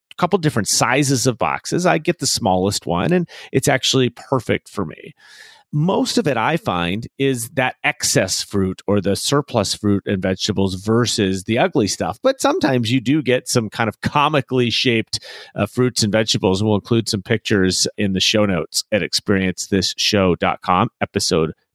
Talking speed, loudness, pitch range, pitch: 165 wpm, -18 LUFS, 100-135 Hz, 115 Hz